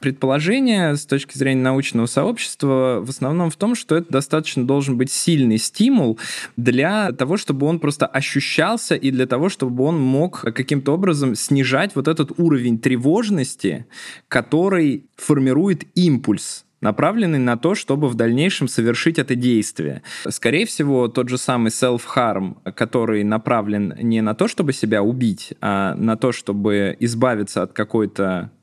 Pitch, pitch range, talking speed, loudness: 135 Hz, 120-155 Hz, 145 wpm, -19 LUFS